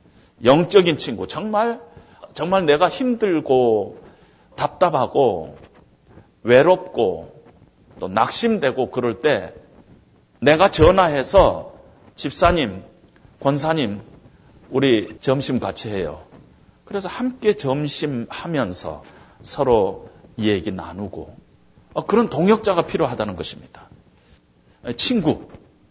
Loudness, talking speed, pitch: -19 LUFS, 195 characters per minute, 145 Hz